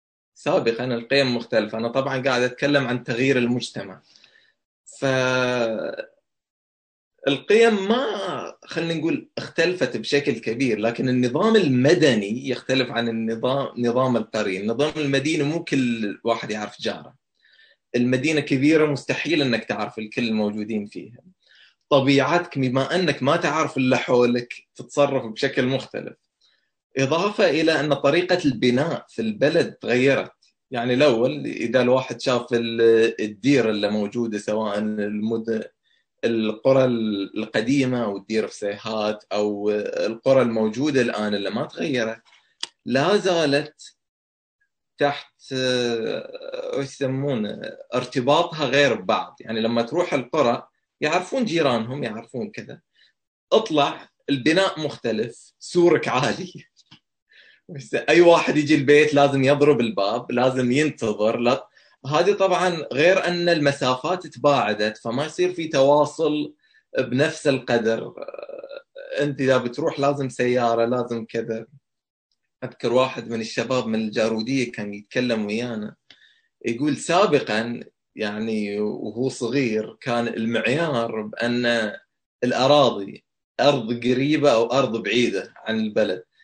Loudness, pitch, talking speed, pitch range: -22 LUFS, 125 Hz, 110 wpm, 115-145 Hz